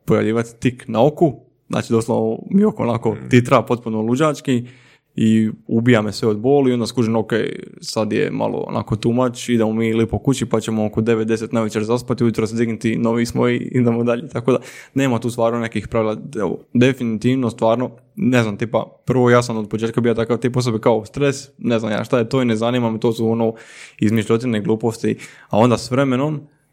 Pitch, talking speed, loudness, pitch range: 115 Hz, 195 wpm, -19 LUFS, 110-125 Hz